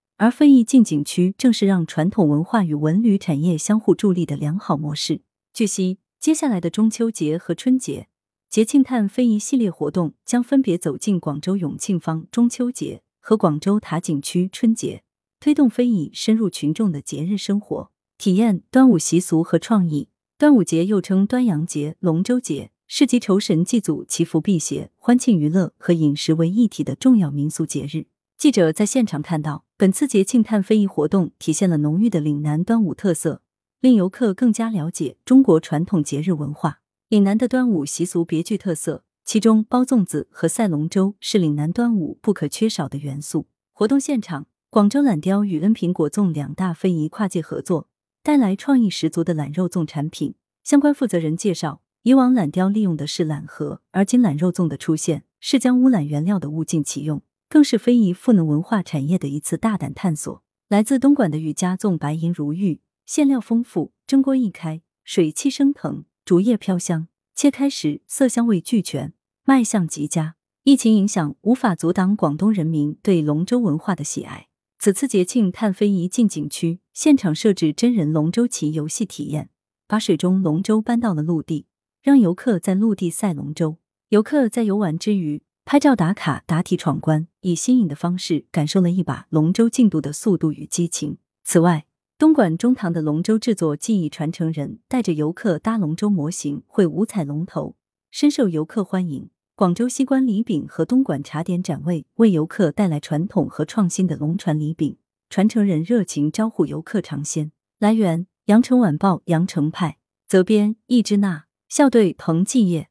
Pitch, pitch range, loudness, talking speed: 185 Hz, 155-225 Hz, -20 LUFS, 280 characters per minute